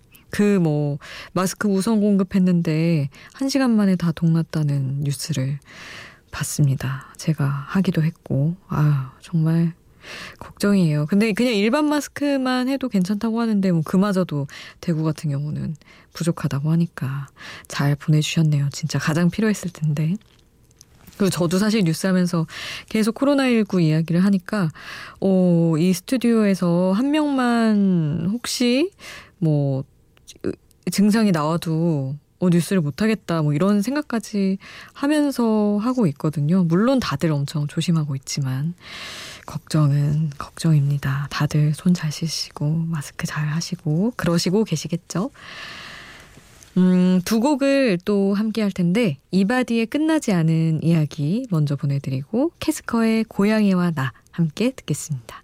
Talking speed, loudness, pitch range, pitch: 280 characters per minute, -21 LUFS, 155-210 Hz, 175 Hz